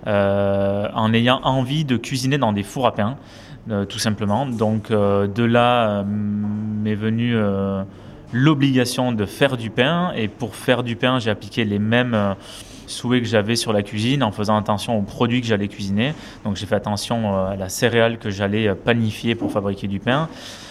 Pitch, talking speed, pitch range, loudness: 110 Hz, 190 wpm, 105-120 Hz, -20 LUFS